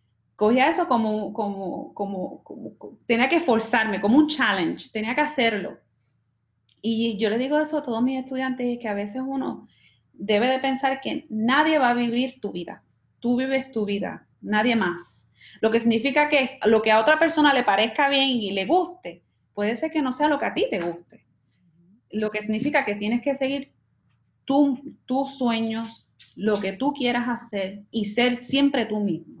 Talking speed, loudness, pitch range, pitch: 190 wpm, -23 LUFS, 210-270 Hz, 235 Hz